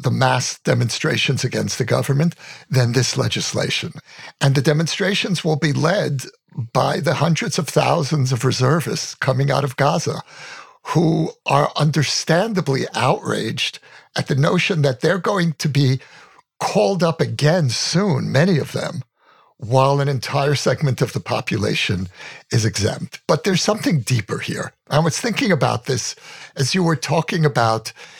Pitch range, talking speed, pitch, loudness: 130-170 Hz, 145 wpm, 150 Hz, -19 LUFS